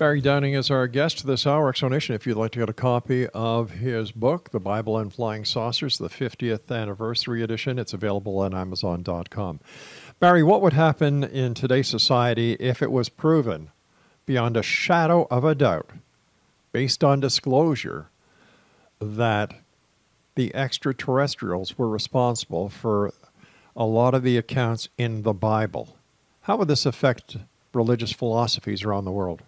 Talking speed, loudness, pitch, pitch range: 150 wpm, -23 LUFS, 120 Hz, 110-135 Hz